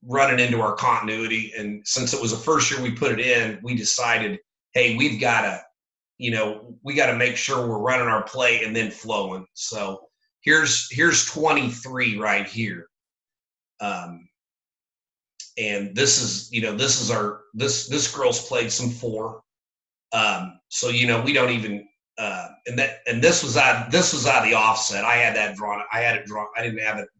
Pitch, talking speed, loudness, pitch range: 115 Hz, 195 wpm, -21 LUFS, 105-130 Hz